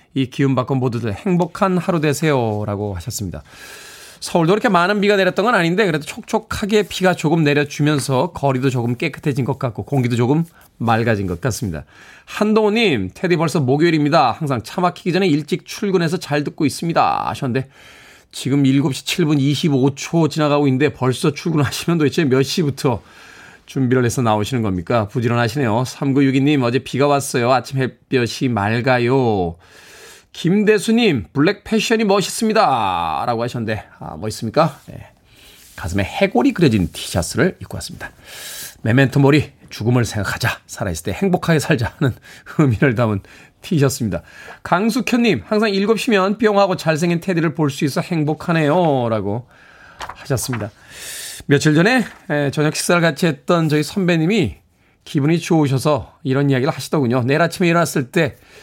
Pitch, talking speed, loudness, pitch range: 145 Hz, 355 characters per minute, -18 LUFS, 125-175 Hz